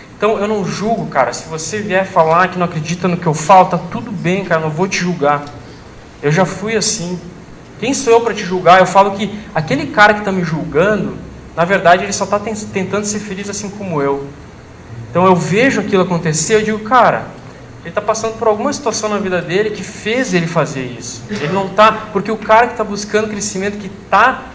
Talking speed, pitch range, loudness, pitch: 220 wpm, 170-215 Hz, -14 LUFS, 195 Hz